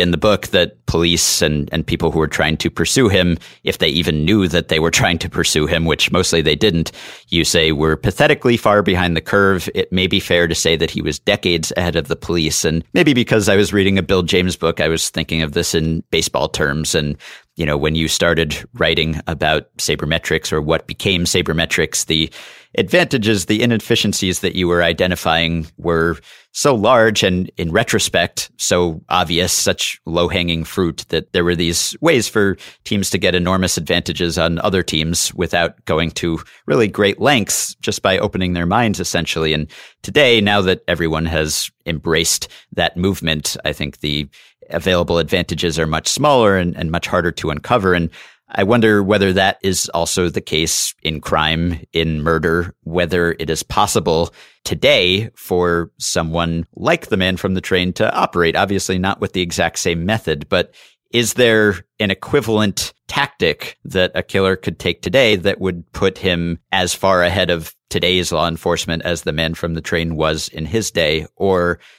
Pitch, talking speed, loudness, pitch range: 85 Hz, 185 wpm, -16 LUFS, 80-95 Hz